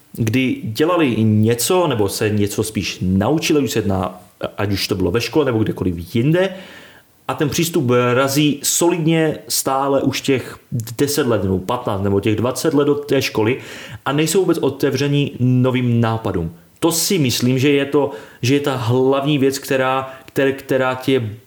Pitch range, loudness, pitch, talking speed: 110-145 Hz, -18 LUFS, 130 Hz, 160 wpm